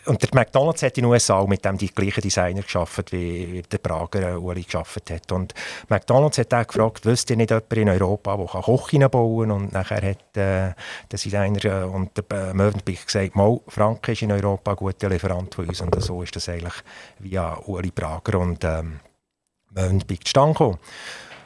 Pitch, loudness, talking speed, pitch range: 100 Hz, -22 LUFS, 195 wpm, 90-110 Hz